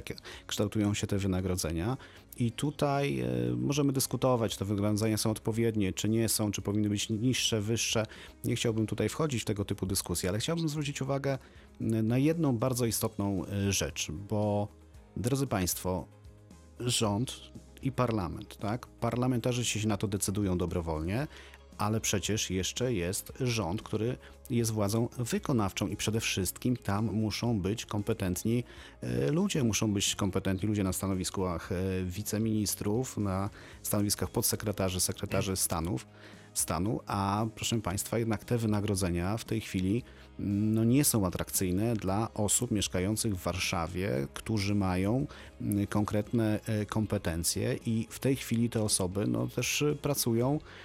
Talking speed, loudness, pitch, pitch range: 130 wpm, -31 LUFS, 105 Hz, 95-115 Hz